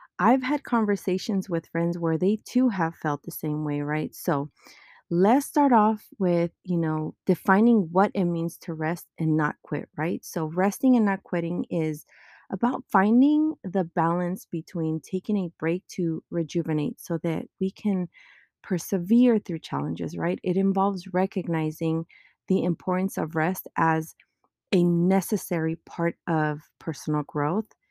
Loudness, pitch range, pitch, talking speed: -26 LUFS, 165-195 Hz, 175 Hz, 150 wpm